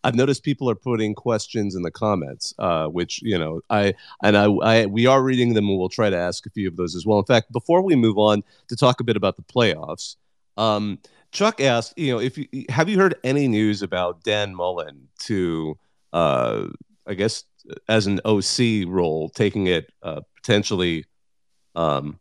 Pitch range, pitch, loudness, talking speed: 90-120 Hz, 105 Hz, -21 LUFS, 190 wpm